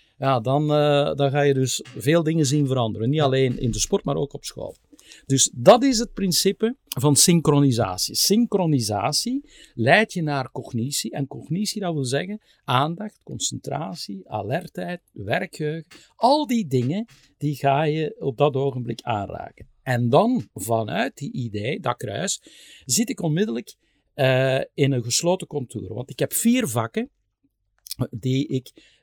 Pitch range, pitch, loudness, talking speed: 130-175 Hz, 145 Hz, -22 LUFS, 150 wpm